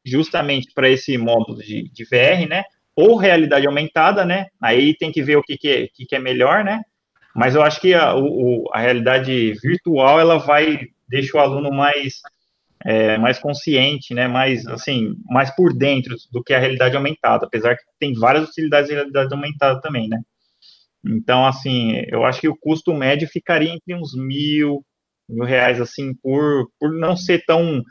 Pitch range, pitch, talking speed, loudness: 125-155 Hz, 140 Hz, 185 wpm, -17 LUFS